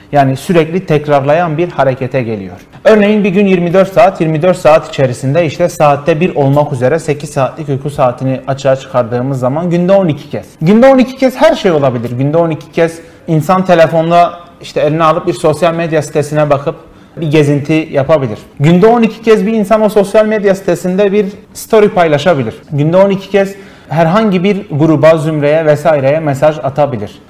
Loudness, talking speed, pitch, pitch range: -10 LUFS, 160 wpm, 160 Hz, 145-185 Hz